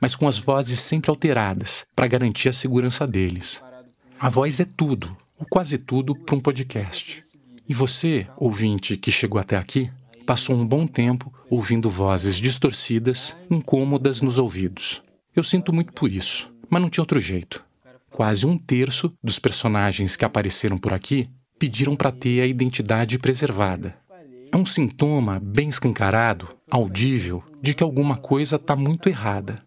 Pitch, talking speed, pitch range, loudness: 130 Hz, 155 wpm, 110-145 Hz, -22 LUFS